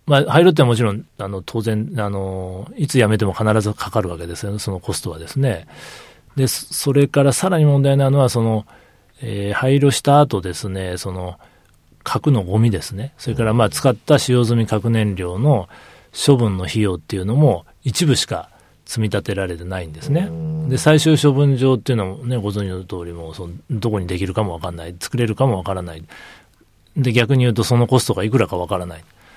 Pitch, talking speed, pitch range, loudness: 110 Hz, 385 characters per minute, 95-135 Hz, -18 LUFS